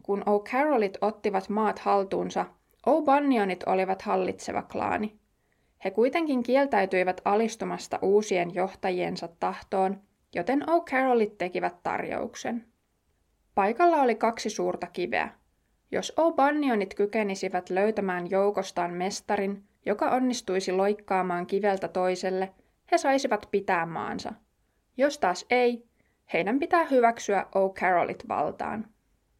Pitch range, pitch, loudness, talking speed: 190-245 Hz, 205 Hz, -27 LUFS, 100 wpm